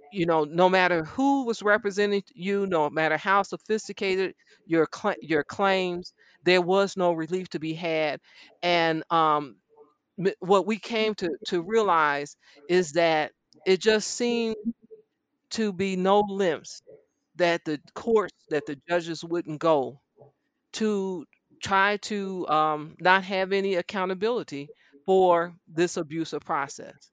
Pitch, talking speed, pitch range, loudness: 185 Hz, 135 wpm, 165-205 Hz, -26 LUFS